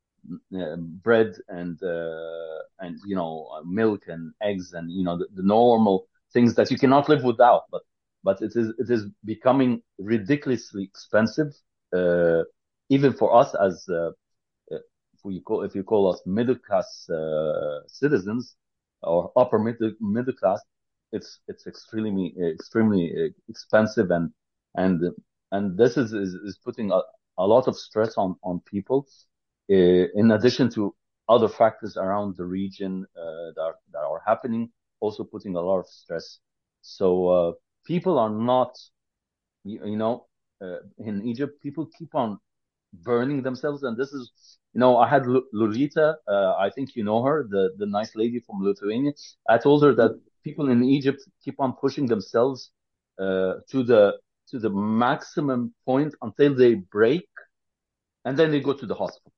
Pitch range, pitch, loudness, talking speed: 95-135 Hz, 115 Hz, -24 LUFS, 160 wpm